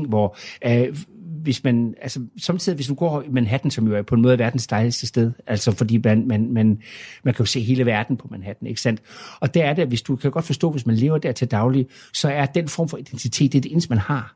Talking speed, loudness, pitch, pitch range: 265 wpm, -21 LUFS, 125 Hz, 115-145 Hz